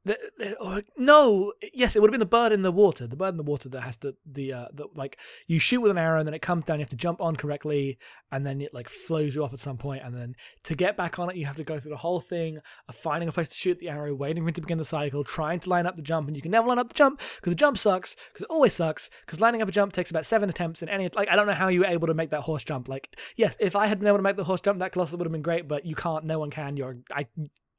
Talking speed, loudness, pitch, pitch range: 335 wpm, -26 LUFS, 165 Hz, 150-200 Hz